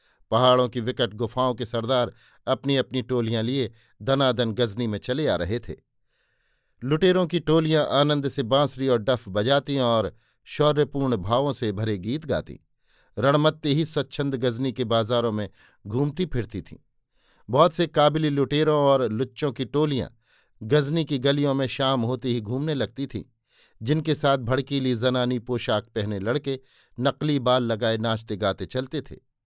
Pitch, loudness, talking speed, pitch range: 130 Hz, -24 LUFS, 155 wpm, 115-140 Hz